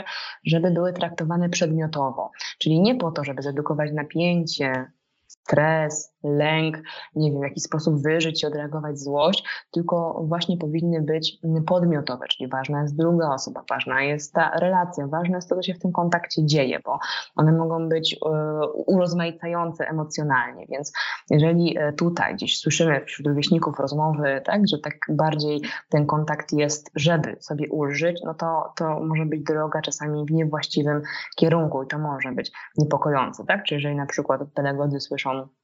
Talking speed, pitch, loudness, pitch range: 155 wpm, 155 Hz, -23 LUFS, 150-165 Hz